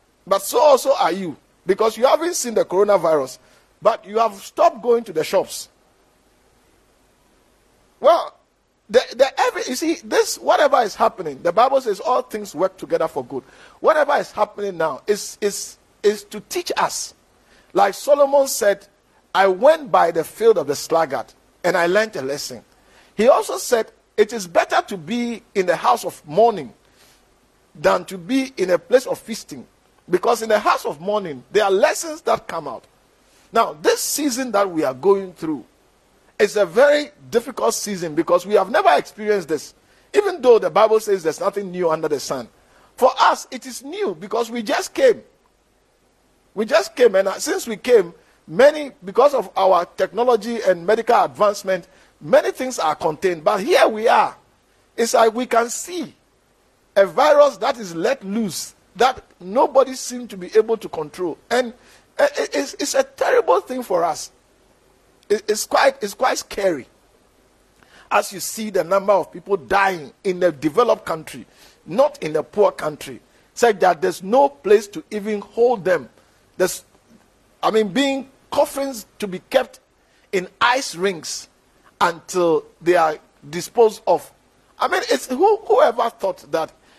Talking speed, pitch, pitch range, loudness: 165 wpm, 225 Hz, 195-285 Hz, -19 LUFS